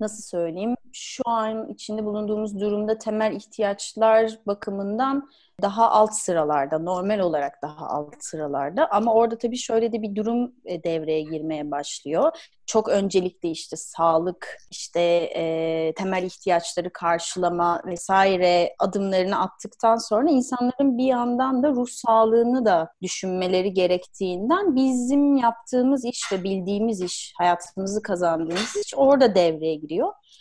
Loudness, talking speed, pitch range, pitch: -23 LUFS, 120 wpm, 175-230 Hz, 205 Hz